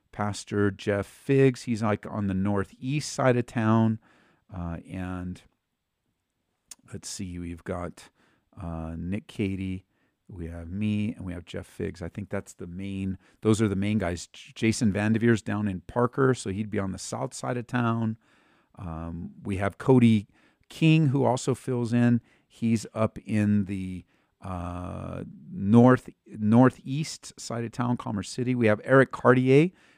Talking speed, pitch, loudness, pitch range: 155 wpm, 105 Hz, -26 LUFS, 95-120 Hz